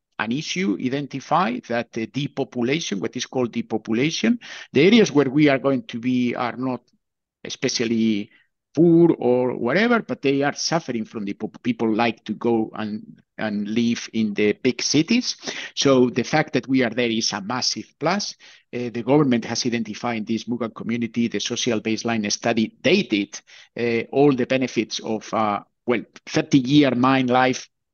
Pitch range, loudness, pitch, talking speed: 115-135 Hz, -22 LUFS, 120 Hz, 160 wpm